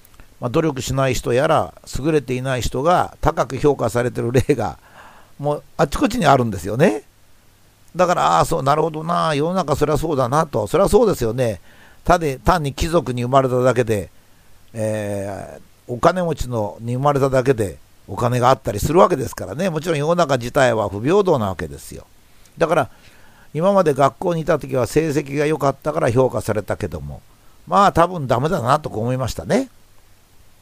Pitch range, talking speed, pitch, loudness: 110-155 Hz, 355 characters per minute, 130 Hz, -19 LUFS